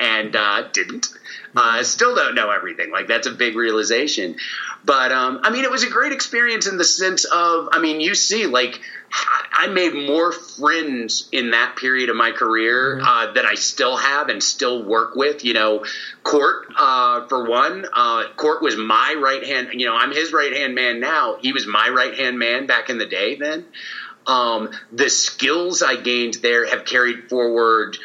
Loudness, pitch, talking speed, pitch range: -18 LUFS, 135 Hz, 195 wpm, 120-180 Hz